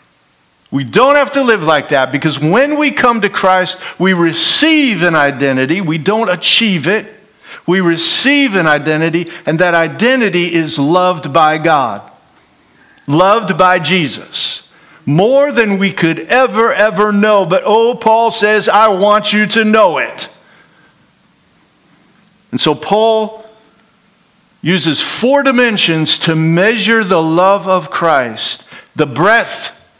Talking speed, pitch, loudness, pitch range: 130 wpm, 195 Hz, -11 LUFS, 165-220 Hz